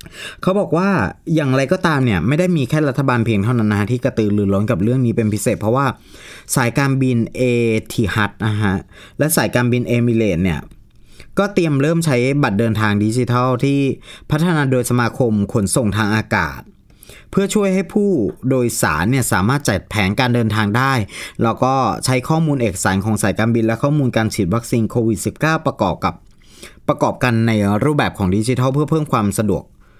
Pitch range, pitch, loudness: 110-140 Hz, 120 Hz, -17 LUFS